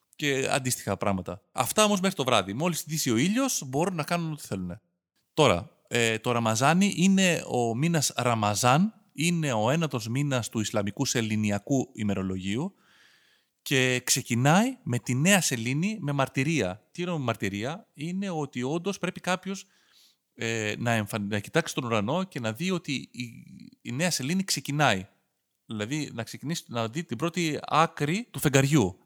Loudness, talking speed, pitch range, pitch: -27 LUFS, 155 wpm, 115-170 Hz, 140 Hz